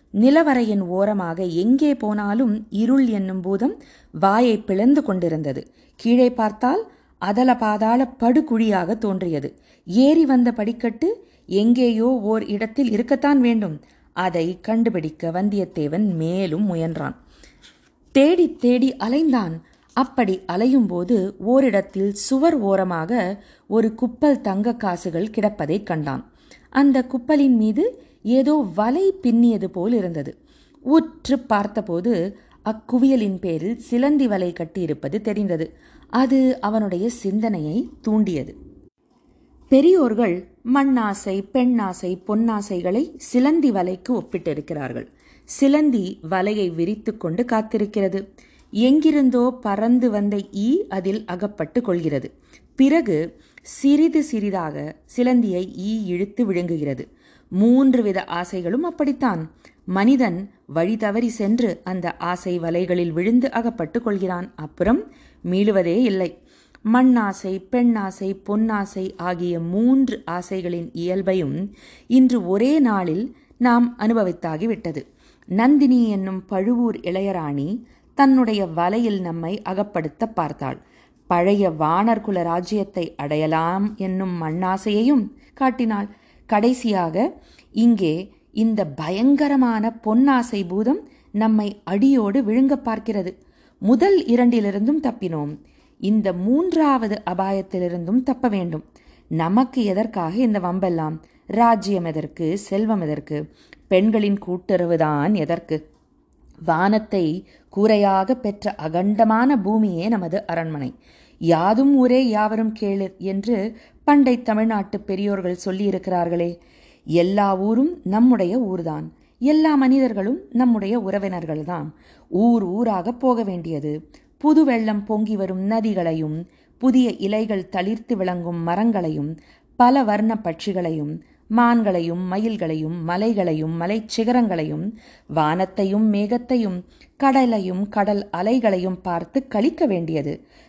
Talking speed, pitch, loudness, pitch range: 95 wpm, 210 Hz, -20 LUFS, 180-245 Hz